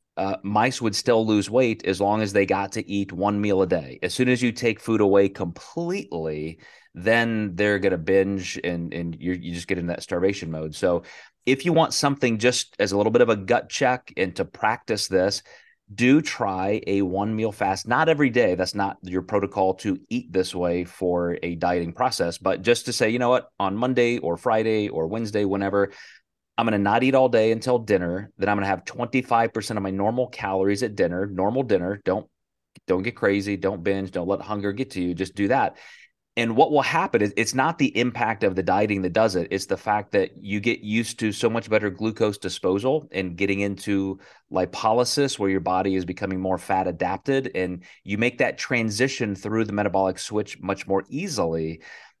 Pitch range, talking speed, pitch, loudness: 95-115 Hz, 210 wpm, 100 Hz, -23 LUFS